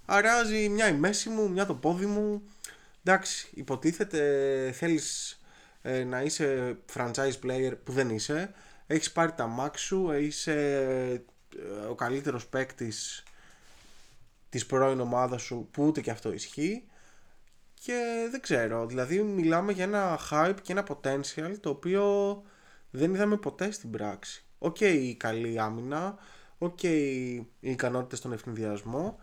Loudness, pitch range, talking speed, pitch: -30 LUFS, 125-190 Hz, 135 wpm, 145 Hz